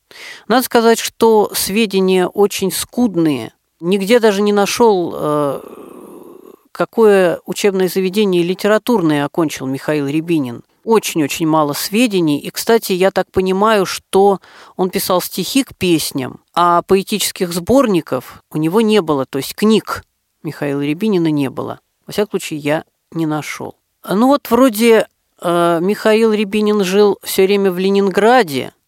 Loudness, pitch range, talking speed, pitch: -15 LUFS, 165-220 Hz, 125 wpm, 190 Hz